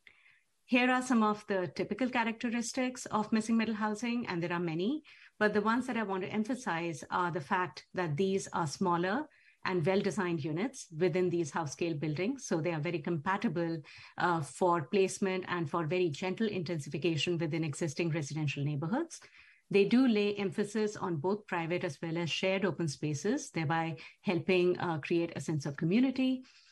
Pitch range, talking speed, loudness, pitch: 170-215 Hz, 175 wpm, -33 LUFS, 185 Hz